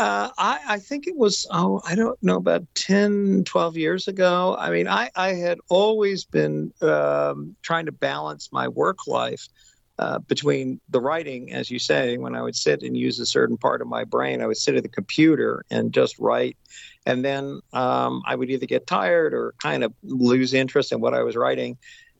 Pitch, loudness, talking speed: 130 Hz, -23 LUFS, 205 wpm